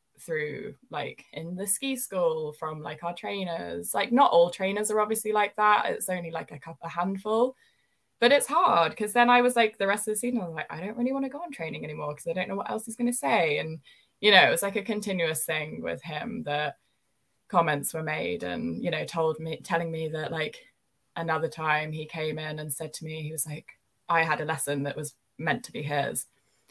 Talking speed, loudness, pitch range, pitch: 240 wpm, -27 LUFS, 150-210 Hz, 165 Hz